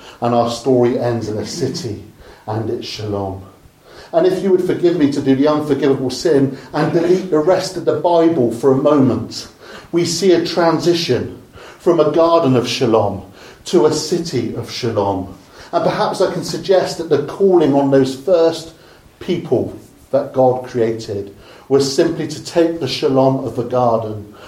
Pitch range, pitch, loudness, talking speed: 120-170 Hz, 140 Hz, -16 LUFS, 170 wpm